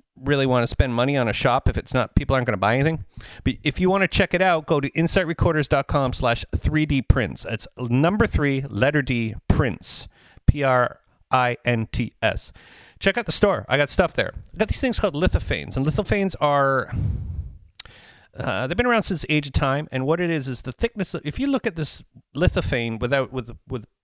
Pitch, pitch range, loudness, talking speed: 130 Hz, 115-155 Hz, -22 LUFS, 200 wpm